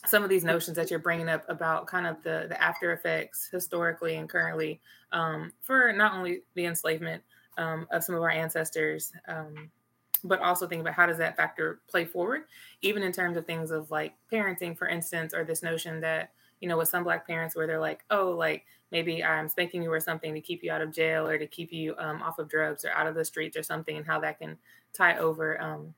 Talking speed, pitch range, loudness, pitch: 230 wpm, 160-175 Hz, -29 LUFS, 165 Hz